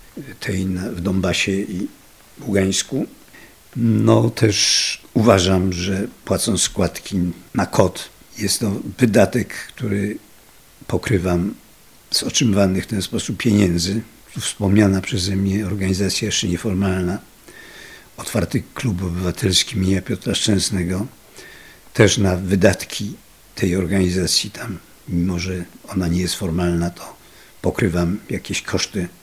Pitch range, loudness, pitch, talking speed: 90-100 Hz, -19 LUFS, 95 Hz, 115 wpm